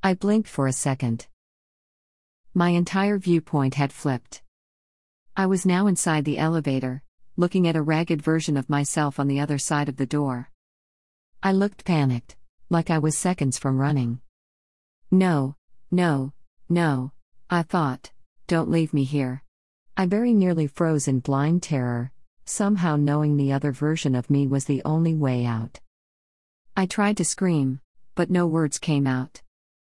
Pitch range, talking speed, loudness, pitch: 130-175 Hz, 155 wpm, -24 LUFS, 145 Hz